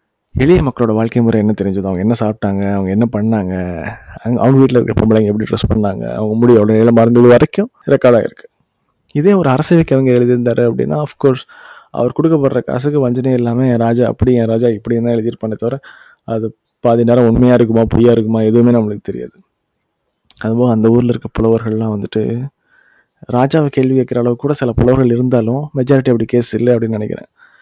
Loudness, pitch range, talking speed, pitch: -13 LUFS, 110-125 Hz, 175 wpm, 120 Hz